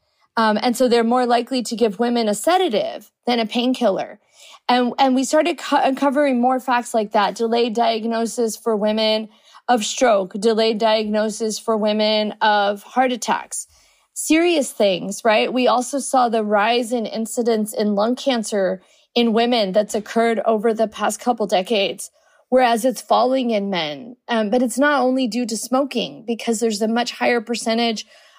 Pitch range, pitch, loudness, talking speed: 220-255 Hz, 235 Hz, -19 LUFS, 165 wpm